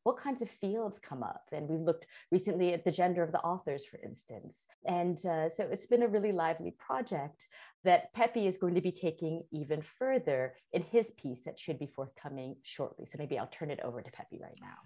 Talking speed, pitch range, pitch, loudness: 220 wpm, 155-210 Hz, 175 Hz, -35 LUFS